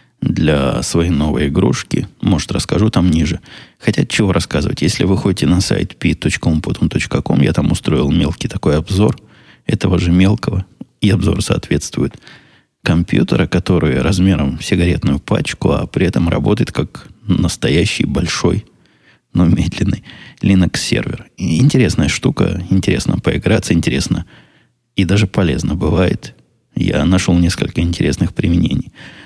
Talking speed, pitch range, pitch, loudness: 125 wpm, 85-95 Hz, 90 Hz, -15 LUFS